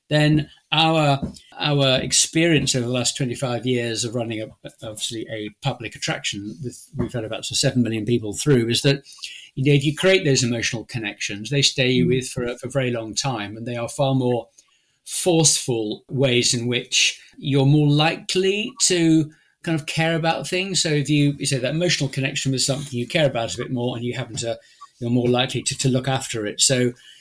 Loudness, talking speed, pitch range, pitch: -20 LUFS, 205 wpm, 120-150 Hz, 130 Hz